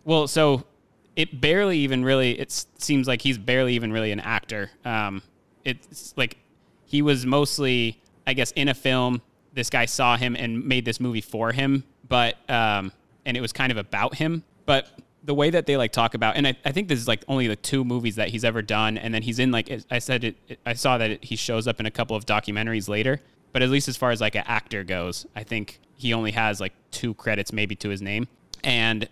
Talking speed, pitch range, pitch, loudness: 235 wpm, 110-135 Hz, 120 Hz, -24 LUFS